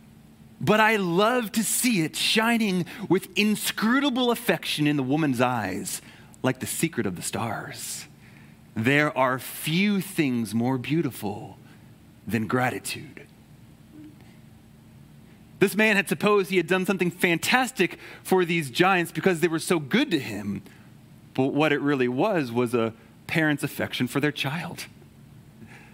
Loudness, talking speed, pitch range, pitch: -24 LUFS, 135 wpm, 130-190 Hz, 160 Hz